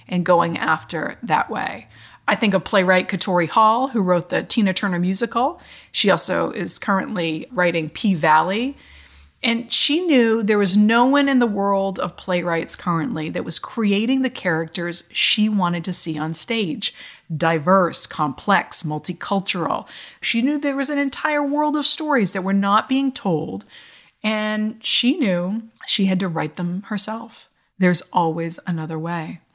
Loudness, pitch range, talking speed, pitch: -19 LUFS, 175-230 Hz, 160 wpm, 195 Hz